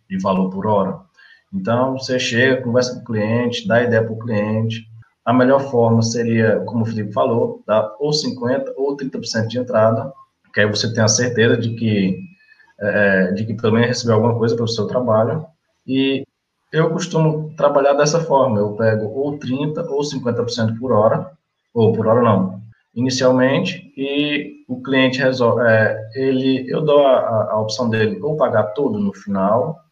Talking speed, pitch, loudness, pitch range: 170 wpm, 120 Hz, -18 LUFS, 110-140 Hz